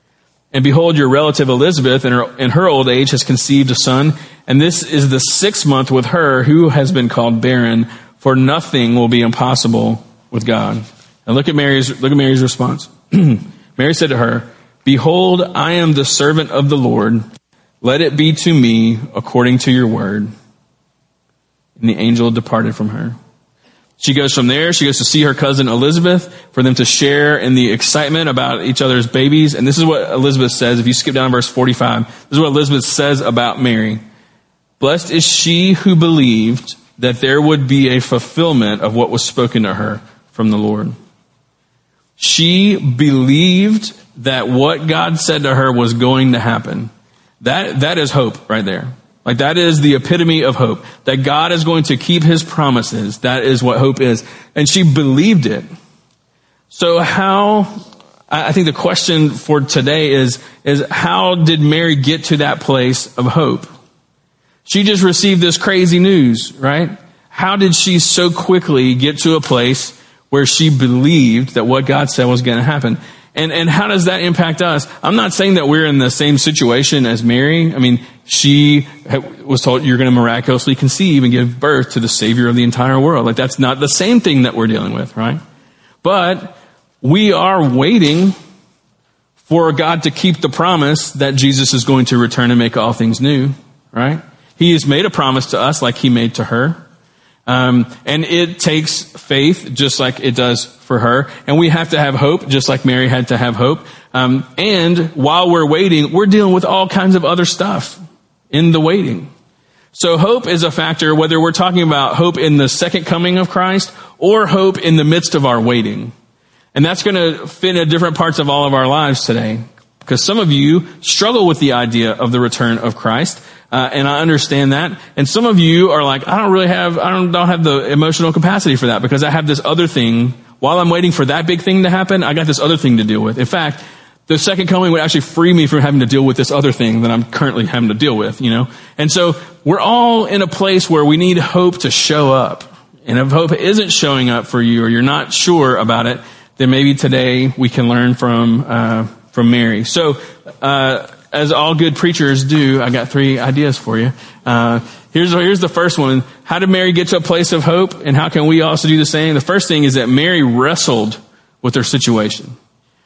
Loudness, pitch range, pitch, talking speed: -12 LUFS, 125-165 Hz, 140 Hz, 200 wpm